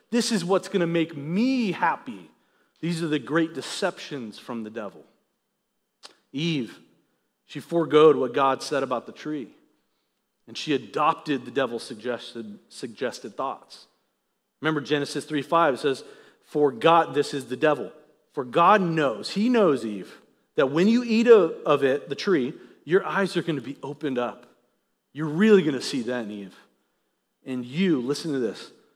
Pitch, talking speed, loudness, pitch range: 155 Hz, 160 wpm, -24 LUFS, 135-190 Hz